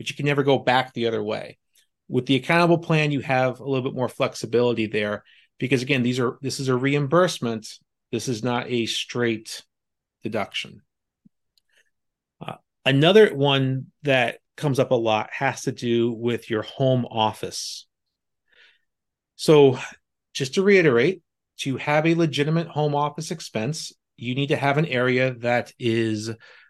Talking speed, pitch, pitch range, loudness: 155 wpm, 130 Hz, 120-145 Hz, -22 LUFS